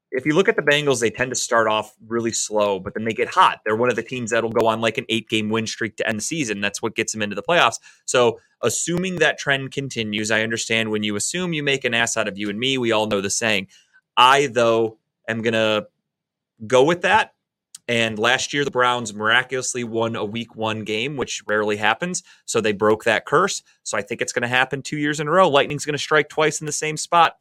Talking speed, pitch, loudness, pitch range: 250 wpm, 115 Hz, -20 LUFS, 110-140 Hz